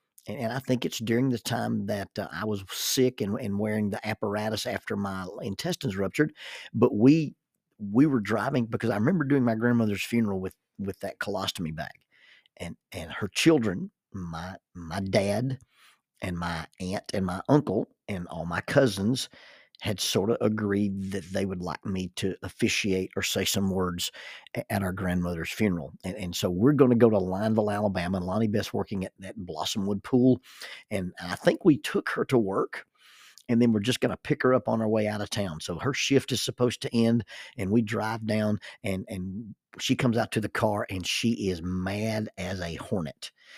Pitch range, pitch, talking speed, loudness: 95-120 Hz, 105 Hz, 195 wpm, -28 LUFS